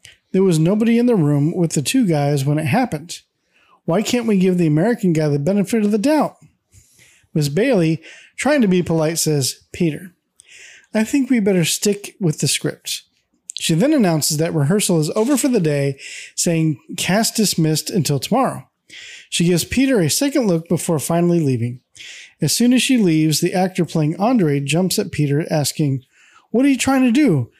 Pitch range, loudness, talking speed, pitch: 155-215 Hz, -17 LUFS, 185 wpm, 175 Hz